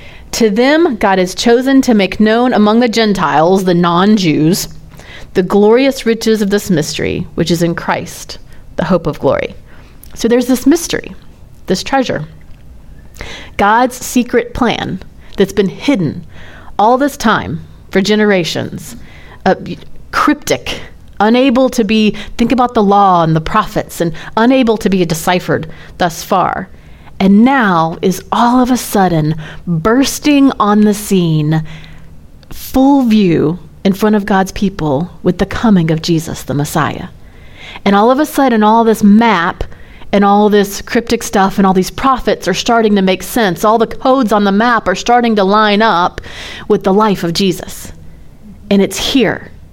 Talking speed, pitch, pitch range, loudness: 155 wpm, 205 Hz, 180-235 Hz, -12 LUFS